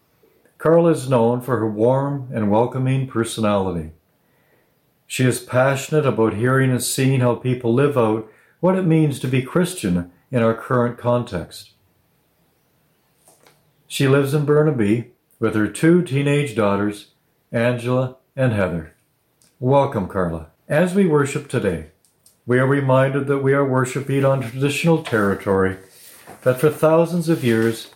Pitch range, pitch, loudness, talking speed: 110-145 Hz, 130 Hz, -19 LUFS, 135 wpm